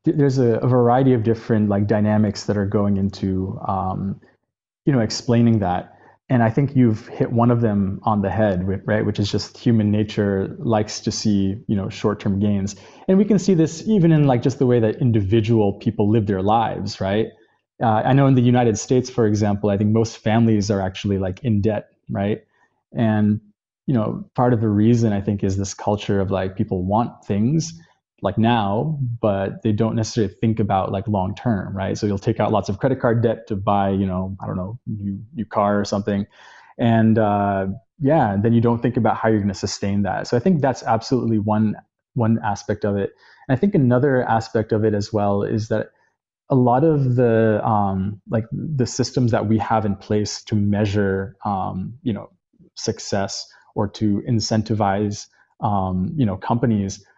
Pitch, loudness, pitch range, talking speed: 110 Hz, -20 LUFS, 100-120 Hz, 200 wpm